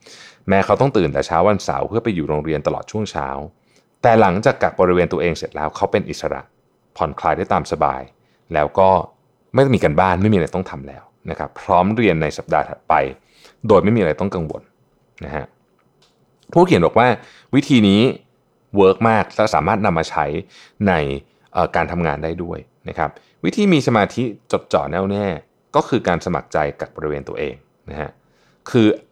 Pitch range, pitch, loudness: 75-105 Hz, 95 Hz, -18 LUFS